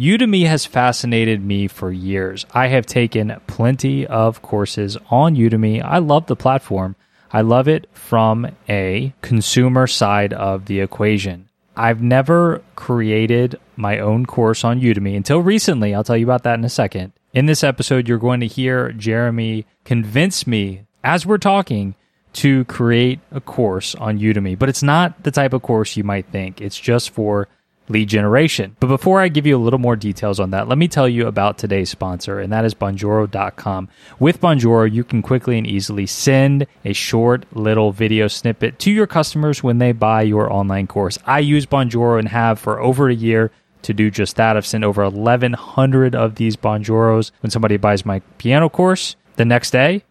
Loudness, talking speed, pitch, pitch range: -16 LUFS, 185 wpm, 115 Hz, 105-130 Hz